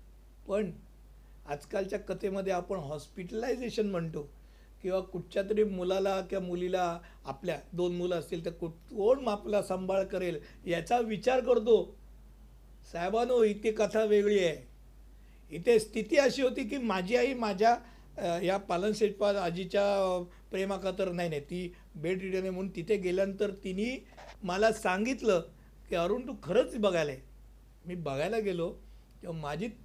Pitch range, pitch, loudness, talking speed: 175-215 Hz, 195 Hz, -31 LUFS, 135 wpm